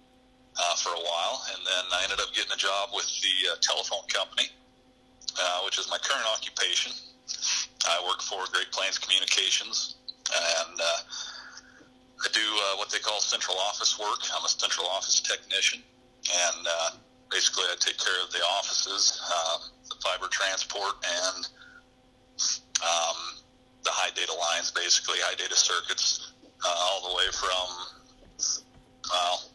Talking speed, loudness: 150 wpm, -27 LUFS